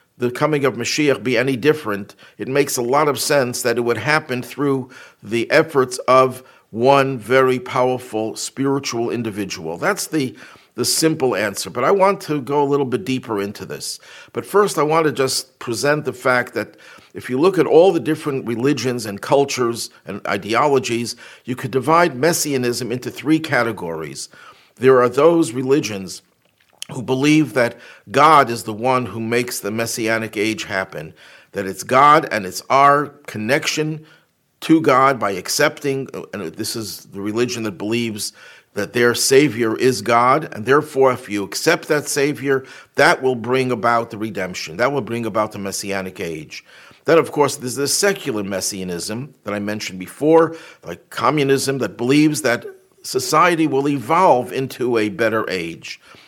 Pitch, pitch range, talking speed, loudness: 130 Hz, 115-145 Hz, 165 wpm, -18 LUFS